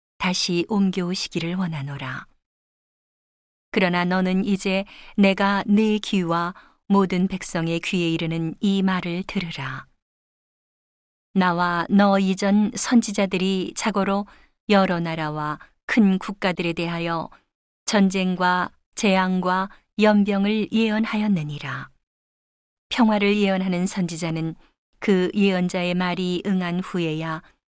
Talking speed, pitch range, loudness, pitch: 225 characters per minute, 170-200 Hz, -22 LUFS, 185 Hz